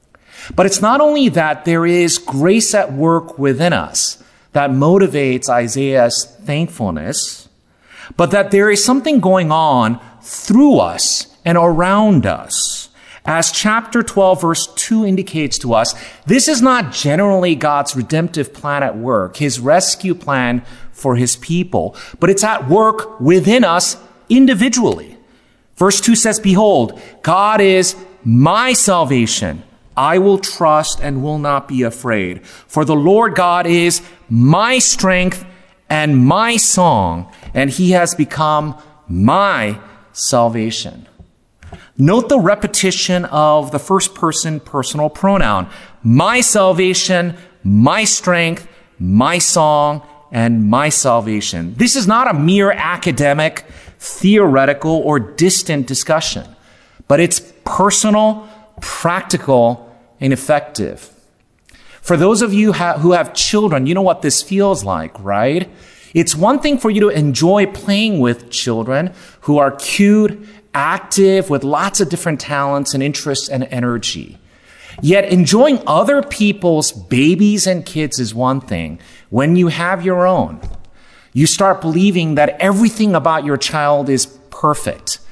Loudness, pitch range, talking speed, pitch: -14 LUFS, 135-195 Hz, 130 wpm, 165 Hz